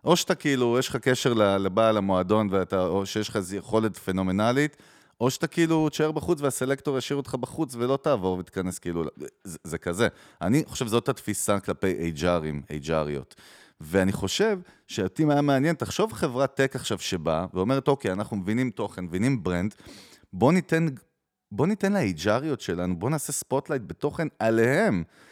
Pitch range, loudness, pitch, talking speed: 95-145 Hz, -26 LUFS, 120 Hz, 160 wpm